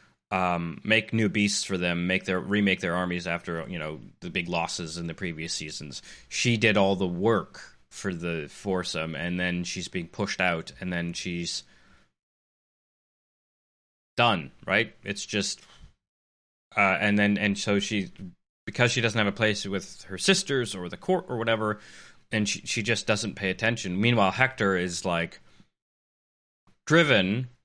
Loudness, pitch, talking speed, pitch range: -27 LUFS, 100 Hz, 160 wpm, 90-110 Hz